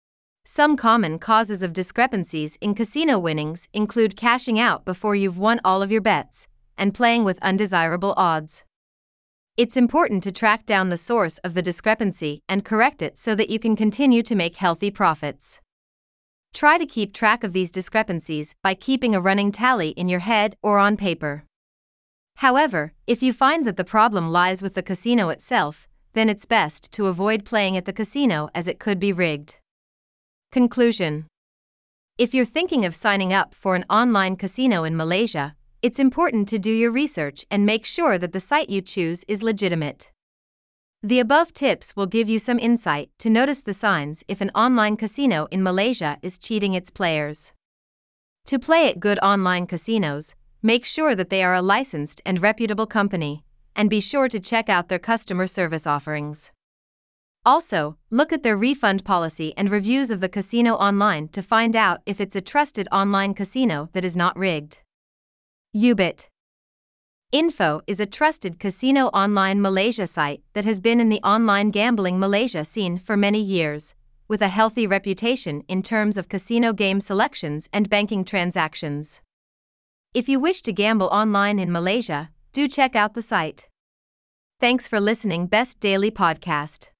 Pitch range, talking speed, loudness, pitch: 180-225 Hz, 170 wpm, -21 LUFS, 200 Hz